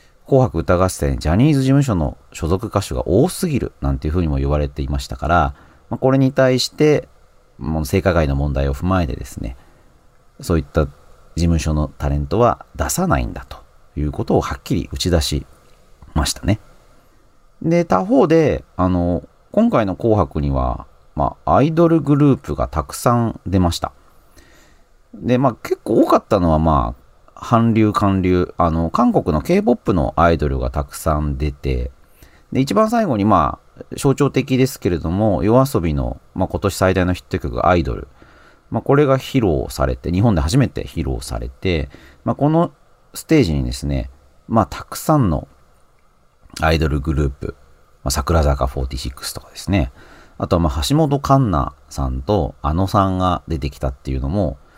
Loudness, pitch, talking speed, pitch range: -18 LUFS, 80 Hz, 315 characters per minute, 70-110 Hz